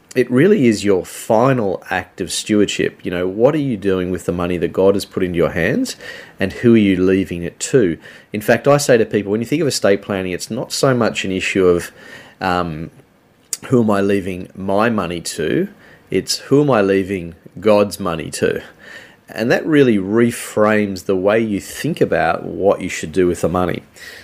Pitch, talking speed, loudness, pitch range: 100 Hz, 205 wpm, -17 LUFS, 90-110 Hz